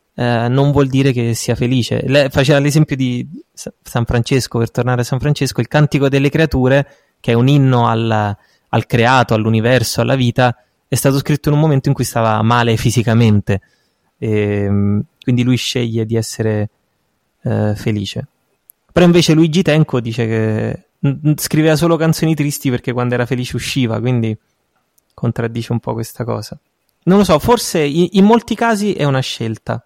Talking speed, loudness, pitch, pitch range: 165 wpm, -15 LUFS, 125 Hz, 115-145 Hz